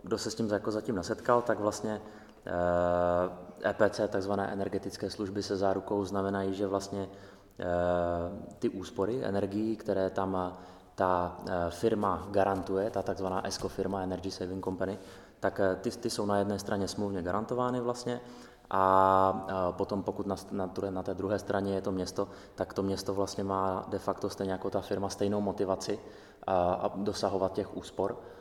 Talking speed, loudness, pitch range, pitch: 155 wpm, -32 LUFS, 95-100 Hz, 100 Hz